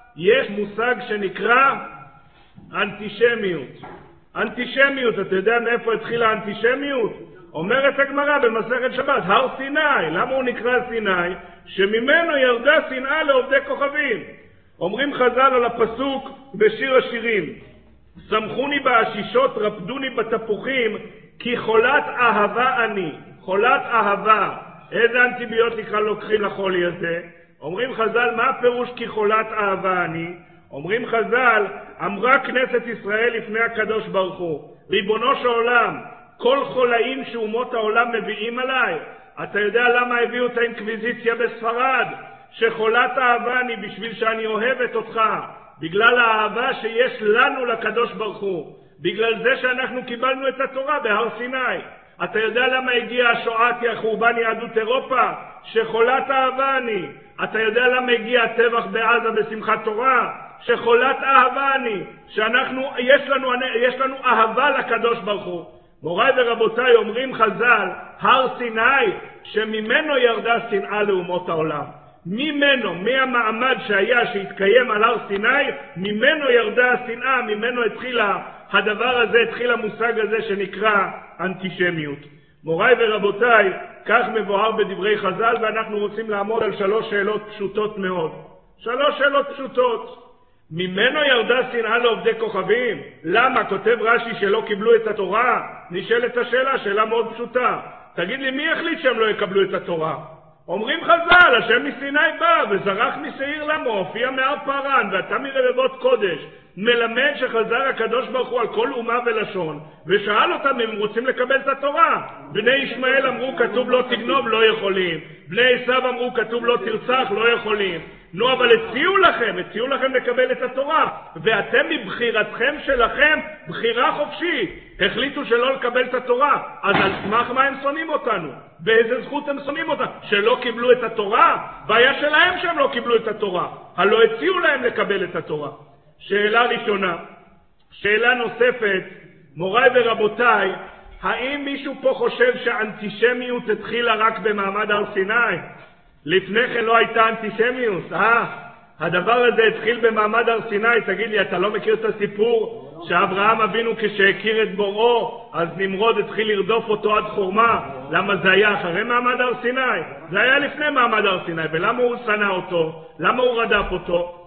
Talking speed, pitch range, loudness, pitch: 135 wpm, 210-260 Hz, -19 LUFS, 235 Hz